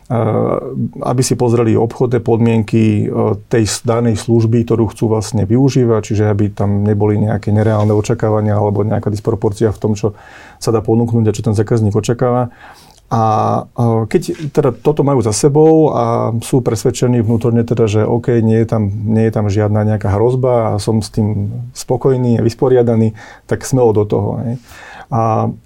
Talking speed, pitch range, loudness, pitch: 155 wpm, 110-120 Hz, -14 LUFS, 115 Hz